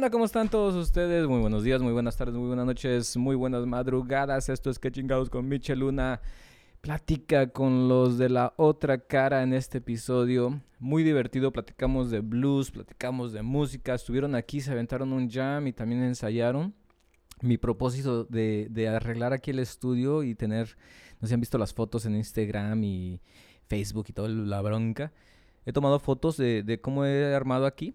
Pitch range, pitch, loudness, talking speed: 115-135 Hz, 125 Hz, -28 LUFS, 180 wpm